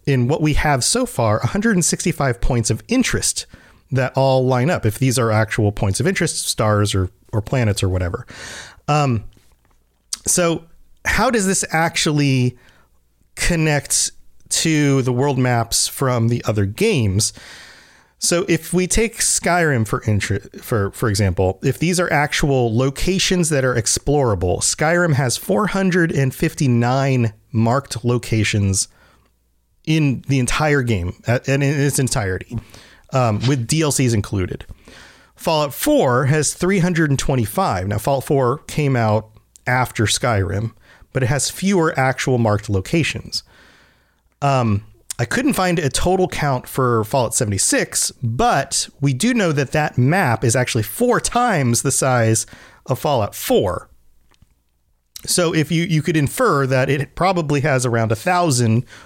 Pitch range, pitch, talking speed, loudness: 110-155 Hz, 130 Hz, 135 wpm, -18 LUFS